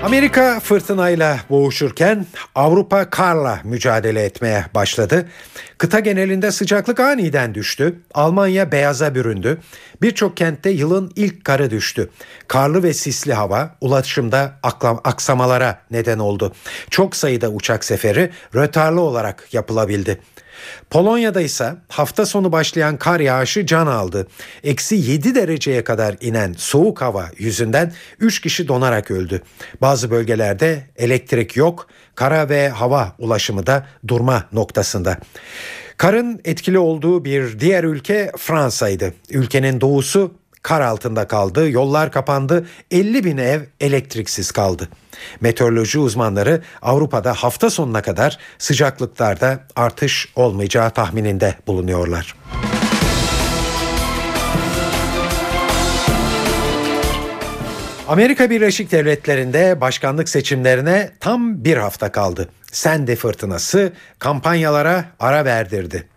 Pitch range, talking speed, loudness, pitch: 115-175 Hz, 100 wpm, -17 LUFS, 140 Hz